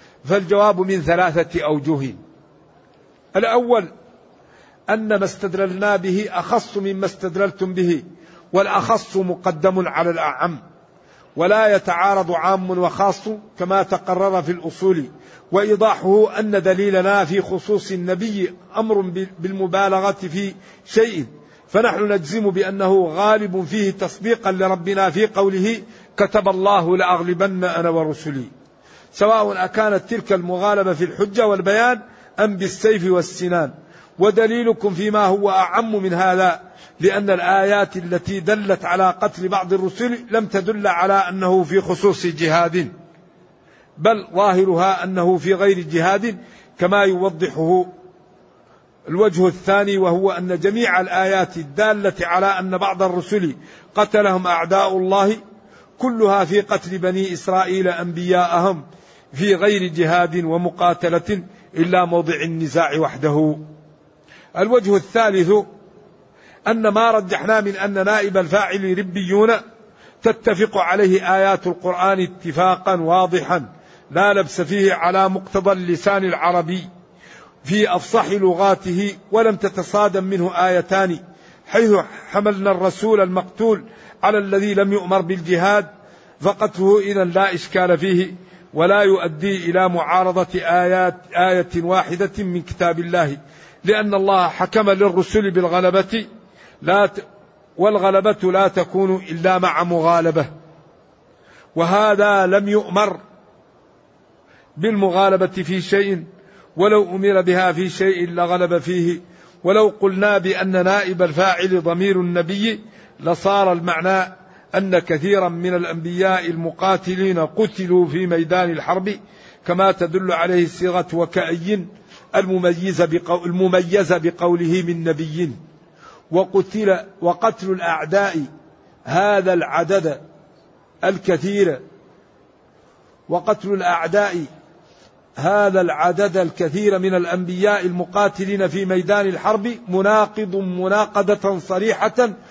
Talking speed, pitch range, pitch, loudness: 100 wpm, 180-200 Hz, 190 Hz, -18 LUFS